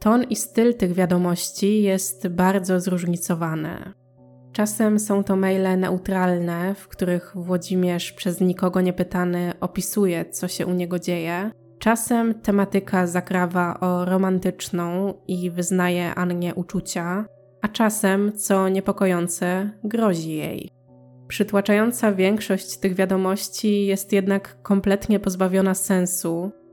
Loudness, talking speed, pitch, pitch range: -22 LUFS, 110 wpm, 185 Hz, 180-200 Hz